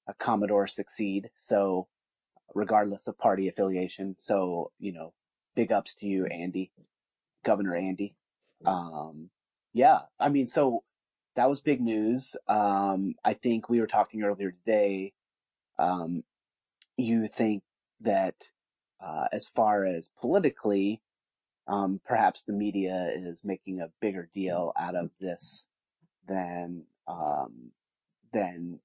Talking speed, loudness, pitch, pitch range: 125 wpm, -29 LUFS, 100 Hz, 90-110 Hz